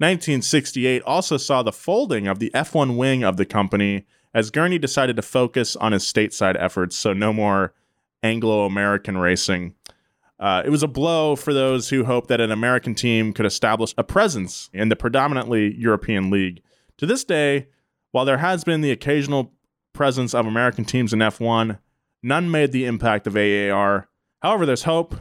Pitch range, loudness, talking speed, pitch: 100-135 Hz, -20 LUFS, 175 wpm, 115 Hz